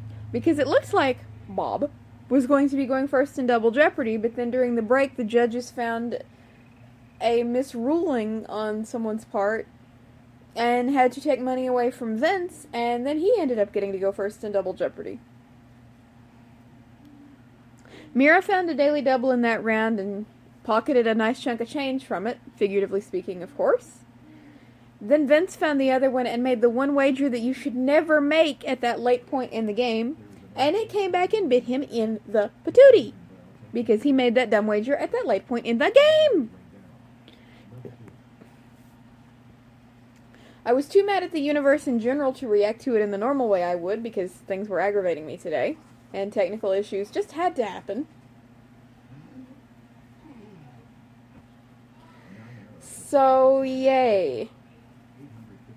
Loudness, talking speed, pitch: -23 LUFS, 160 wpm, 230 Hz